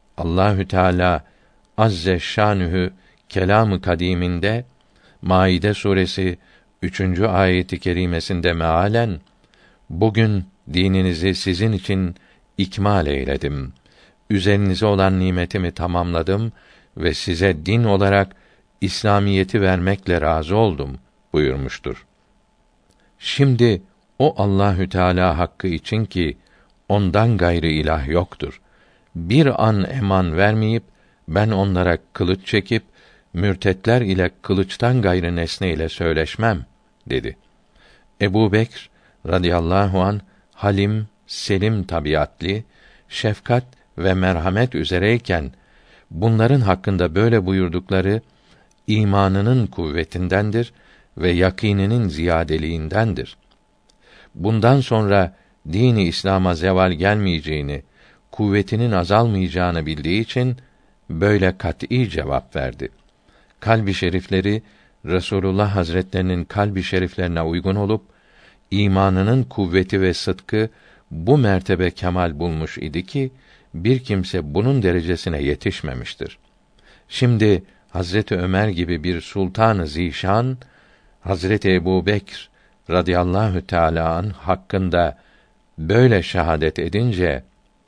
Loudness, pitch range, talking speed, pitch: -19 LUFS, 90-105 Hz, 90 wpm, 95 Hz